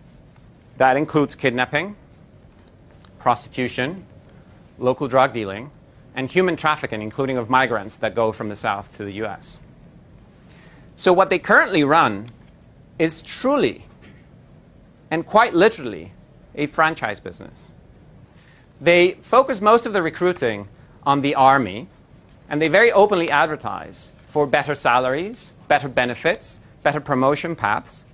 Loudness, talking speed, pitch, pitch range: -19 LUFS, 120 wpm, 140 Hz, 120-160 Hz